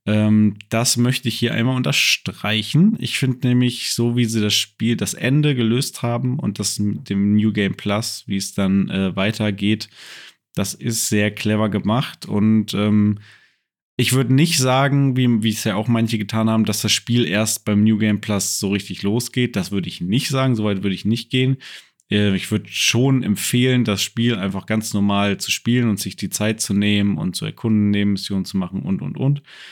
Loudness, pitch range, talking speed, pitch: -19 LUFS, 105-125 Hz, 200 wpm, 110 Hz